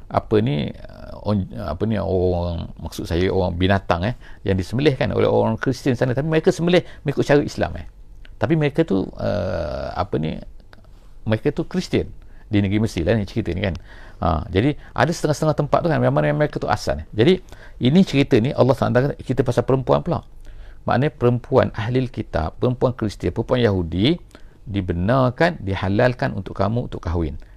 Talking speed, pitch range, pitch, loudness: 170 wpm, 95-135 Hz, 115 Hz, -21 LUFS